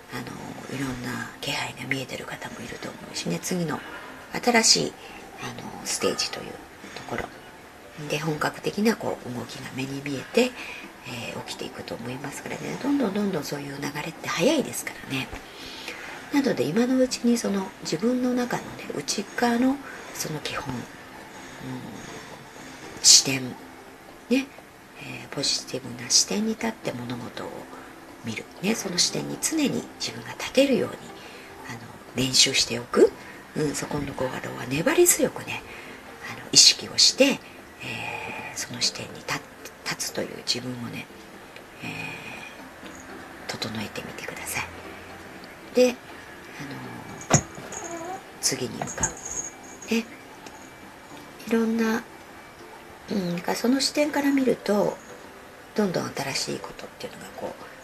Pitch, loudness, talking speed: 215 Hz, -25 LUFS, 265 characters per minute